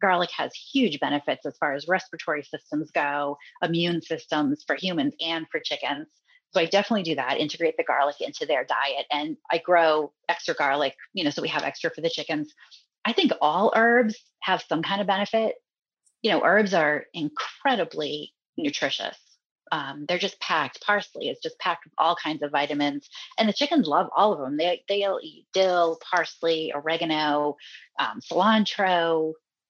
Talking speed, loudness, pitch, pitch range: 170 wpm, -25 LUFS, 175 Hz, 155-220 Hz